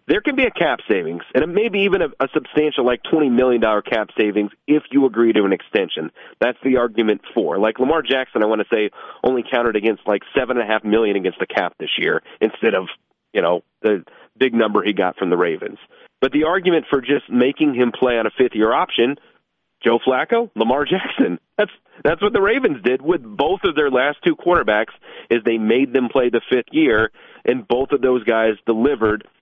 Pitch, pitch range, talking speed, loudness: 125 Hz, 110-150 Hz, 215 wpm, -18 LUFS